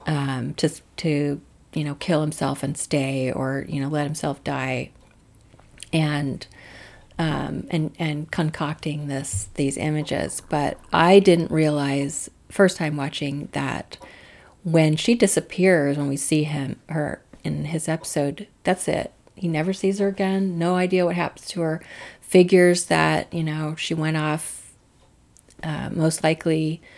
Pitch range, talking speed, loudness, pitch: 140-170 Hz, 145 wpm, -23 LUFS, 155 Hz